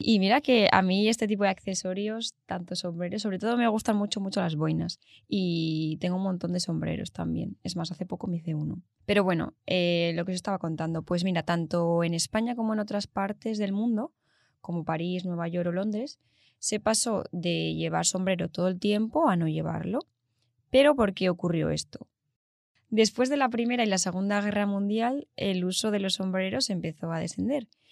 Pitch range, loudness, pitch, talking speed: 170-215 Hz, -28 LUFS, 190 Hz, 195 wpm